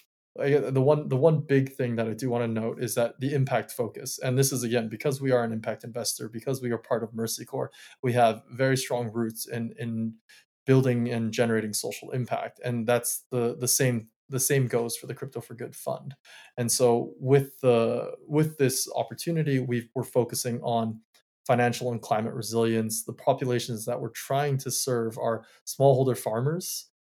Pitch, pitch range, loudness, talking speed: 120 Hz, 115-130 Hz, -27 LUFS, 190 wpm